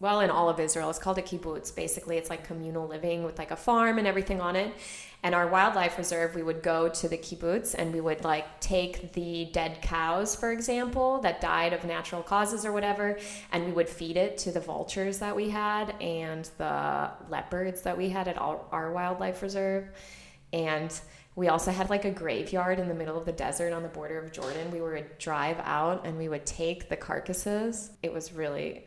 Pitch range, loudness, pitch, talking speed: 165-195 Hz, -30 LUFS, 175 Hz, 210 wpm